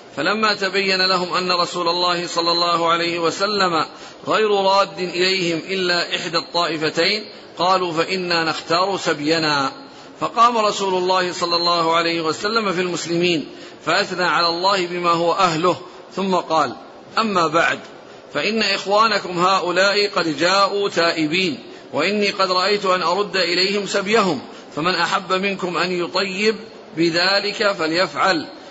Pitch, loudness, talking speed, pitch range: 180 Hz, -18 LUFS, 125 wpm, 170-195 Hz